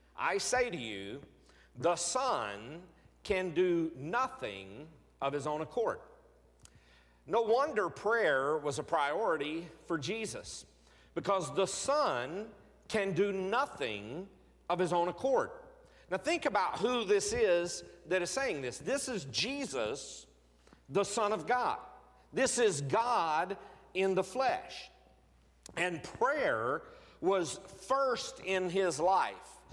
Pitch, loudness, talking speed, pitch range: 190 Hz, -33 LUFS, 125 wpm, 160-250 Hz